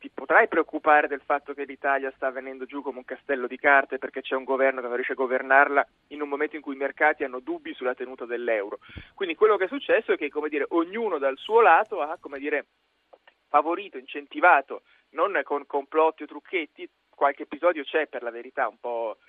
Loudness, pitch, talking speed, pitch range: -25 LUFS, 145 Hz, 210 wpm, 135-165 Hz